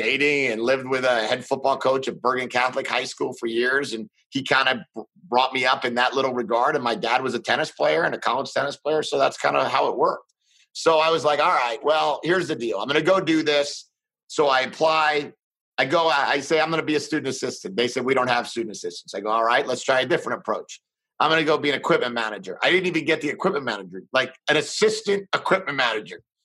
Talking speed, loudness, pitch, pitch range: 250 wpm, -22 LUFS, 140 Hz, 125-155 Hz